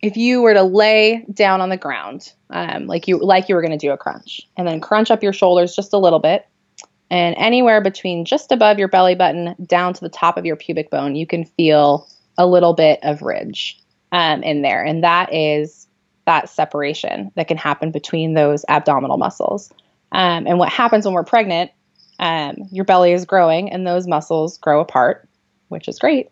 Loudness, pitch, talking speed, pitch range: -16 LUFS, 175 Hz, 200 wpm, 155-190 Hz